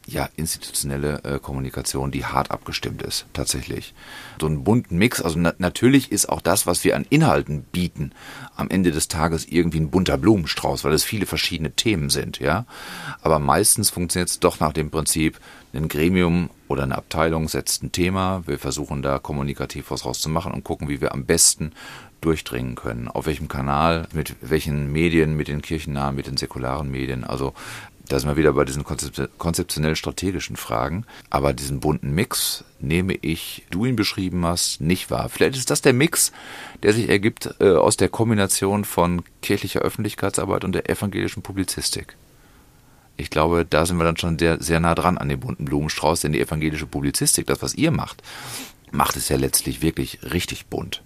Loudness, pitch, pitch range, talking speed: -22 LUFS, 80 Hz, 70-85 Hz, 180 wpm